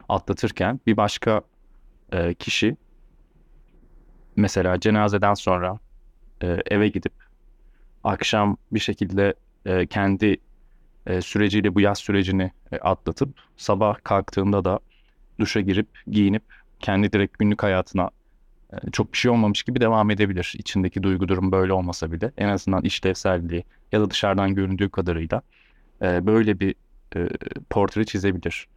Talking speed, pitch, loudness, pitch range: 125 wpm, 100 Hz, -23 LUFS, 95-105 Hz